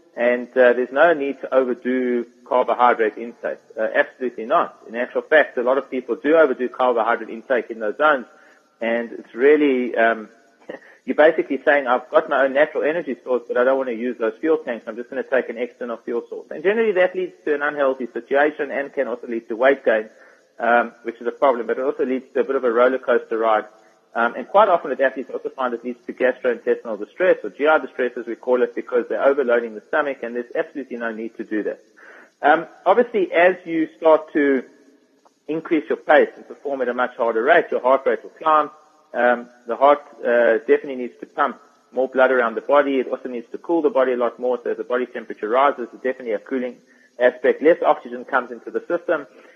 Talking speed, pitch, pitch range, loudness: 220 wpm, 135 Hz, 120-165 Hz, -20 LUFS